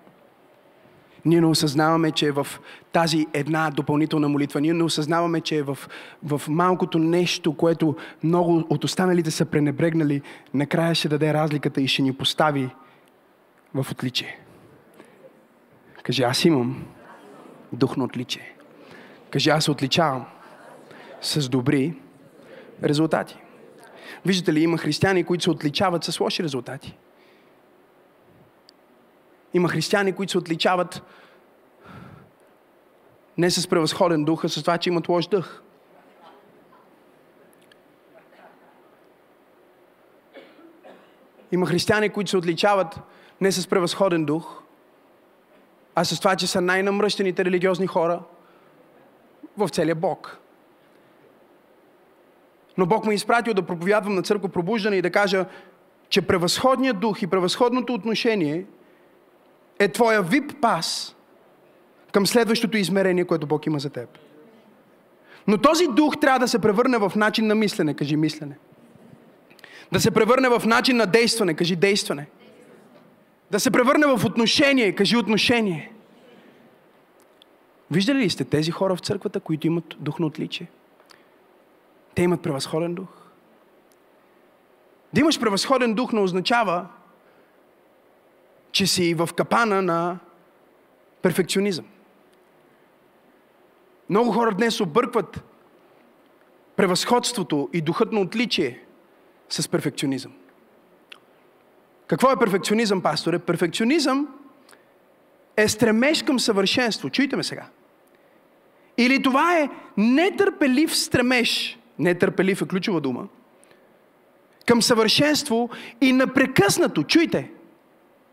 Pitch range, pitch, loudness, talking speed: 165-230 Hz, 185 Hz, -22 LUFS, 110 wpm